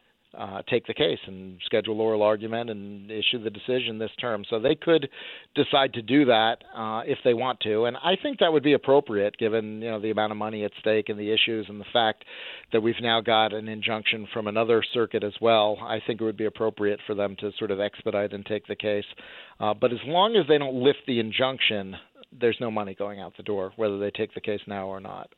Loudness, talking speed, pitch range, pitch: -25 LUFS, 235 wpm, 105-120 Hz, 110 Hz